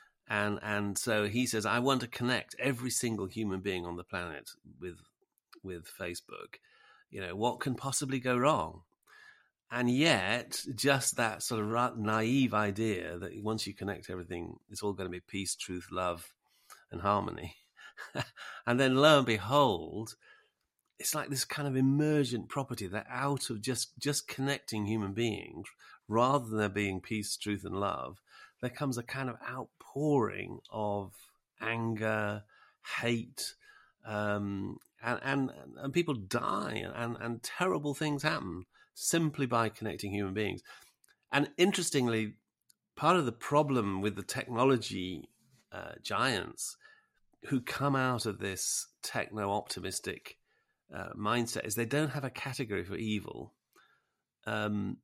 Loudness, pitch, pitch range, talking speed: -33 LUFS, 115 Hz, 105-135 Hz, 145 wpm